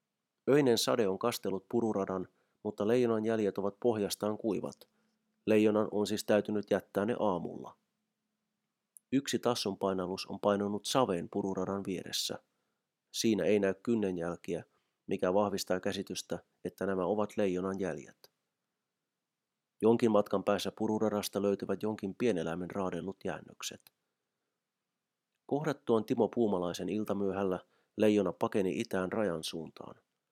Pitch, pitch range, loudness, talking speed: 100 Hz, 95-115 Hz, -33 LUFS, 110 wpm